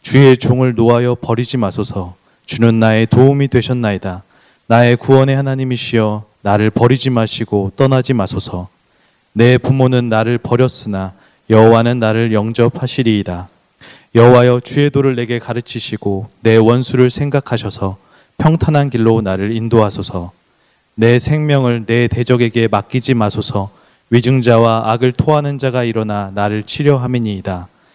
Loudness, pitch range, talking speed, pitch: -13 LUFS, 105-130 Hz, 315 characters per minute, 115 Hz